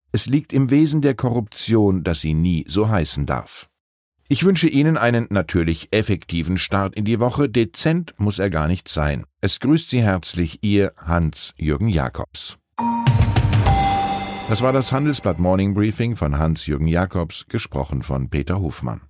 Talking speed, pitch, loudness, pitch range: 150 wpm, 100 Hz, -20 LUFS, 85-120 Hz